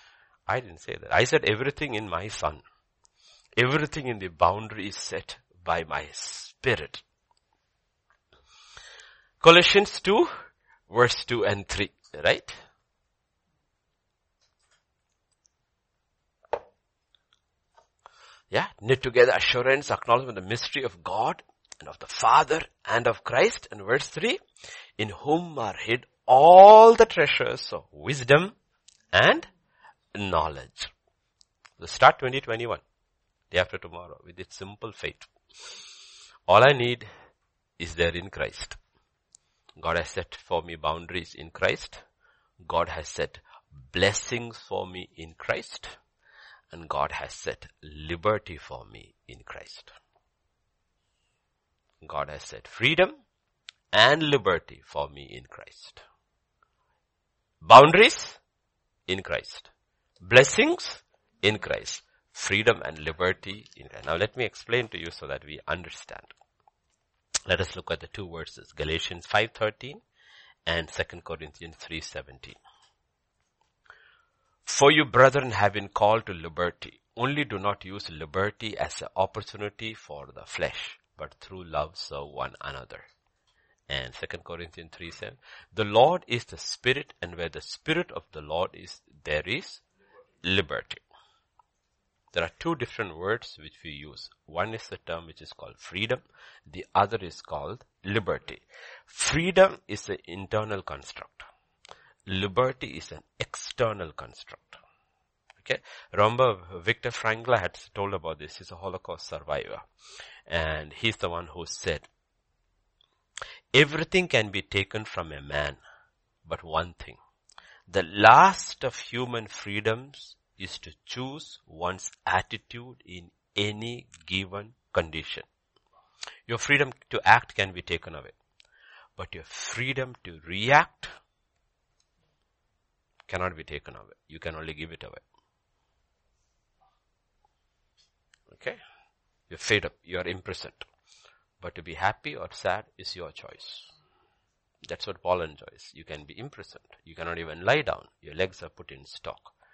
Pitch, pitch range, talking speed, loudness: 100 Hz, 85-125 Hz, 130 wpm, -24 LUFS